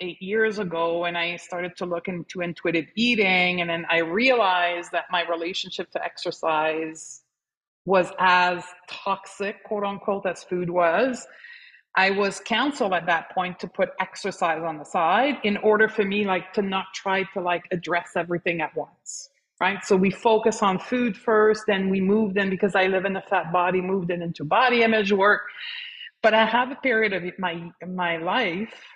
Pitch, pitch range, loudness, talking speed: 190 Hz, 175-210 Hz, -23 LUFS, 180 wpm